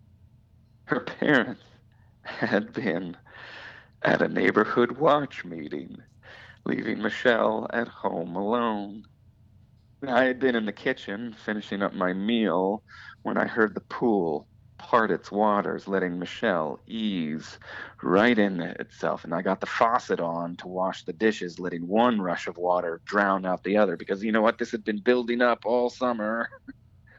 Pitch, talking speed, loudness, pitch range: 105 Hz, 150 wpm, -26 LUFS, 95-115 Hz